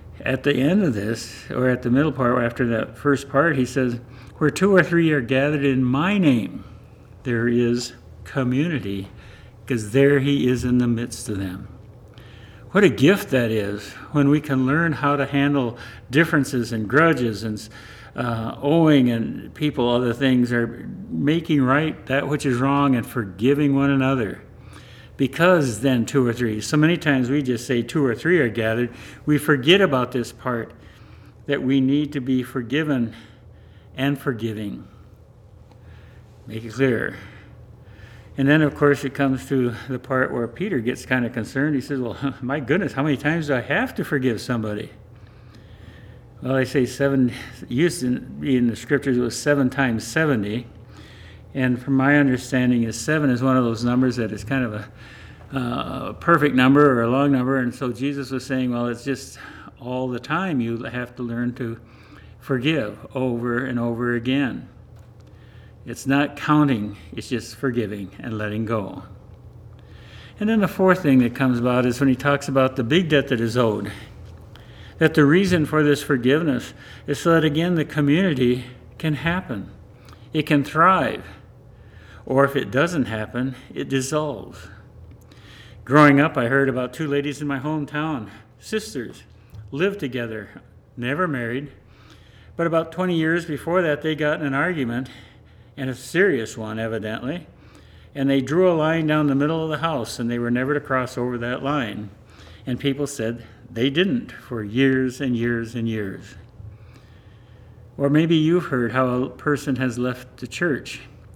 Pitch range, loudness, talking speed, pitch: 115-140 Hz, -21 LUFS, 170 wpm, 125 Hz